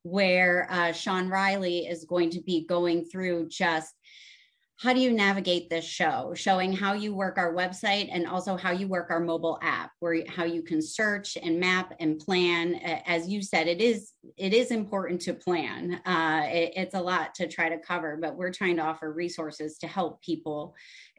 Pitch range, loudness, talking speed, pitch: 170-195 Hz, -28 LUFS, 195 wpm, 175 Hz